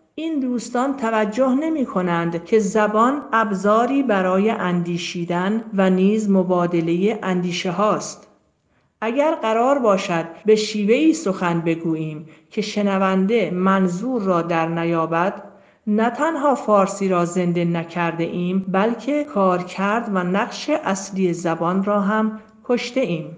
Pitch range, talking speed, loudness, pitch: 175-225 Hz, 120 wpm, -20 LUFS, 195 Hz